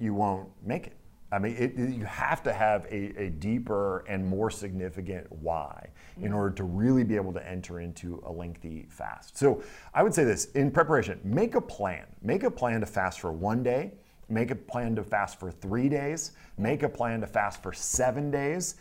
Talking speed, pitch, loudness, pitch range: 205 wpm, 105 Hz, -30 LUFS, 95-125 Hz